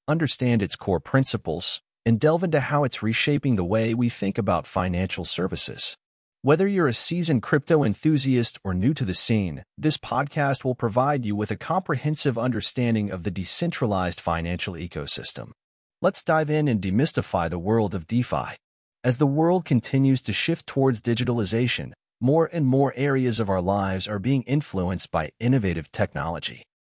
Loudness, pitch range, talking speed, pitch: -24 LUFS, 100-145 Hz, 160 wpm, 120 Hz